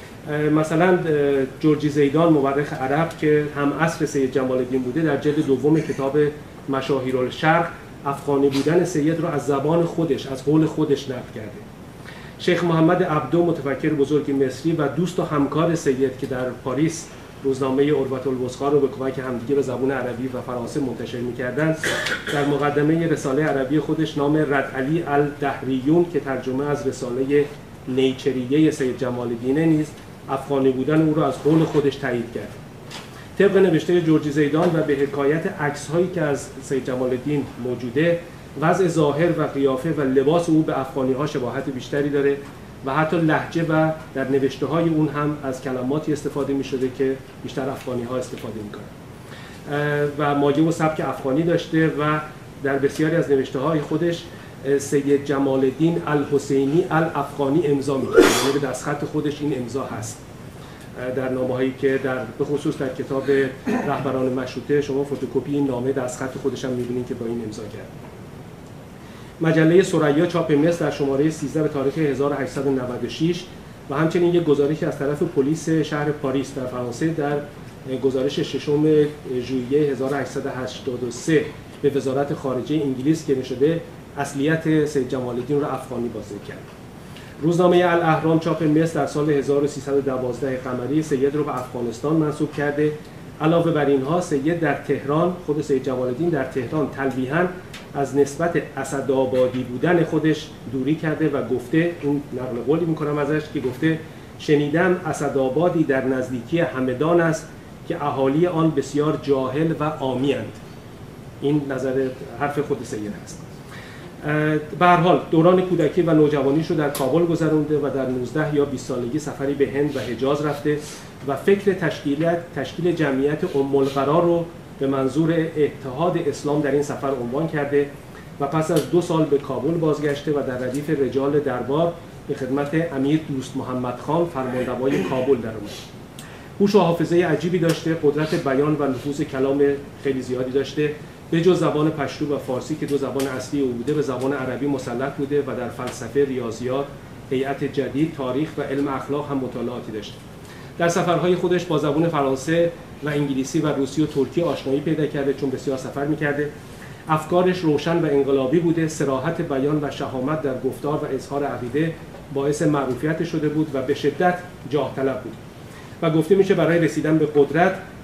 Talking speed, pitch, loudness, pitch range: 155 wpm, 145 Hz, -22 LUFS, 135-155 Hz